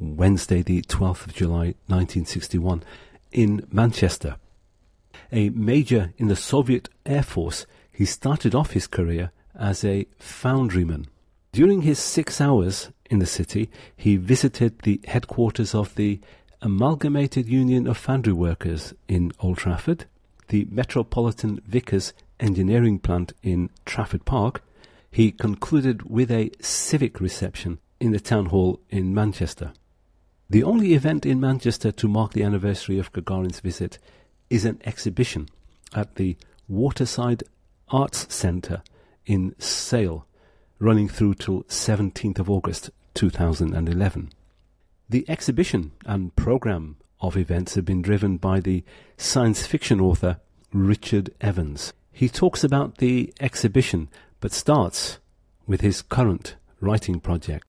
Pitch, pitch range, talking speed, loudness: 100 Hz, 90-120 Hz, 125 wpm, -23 LUFS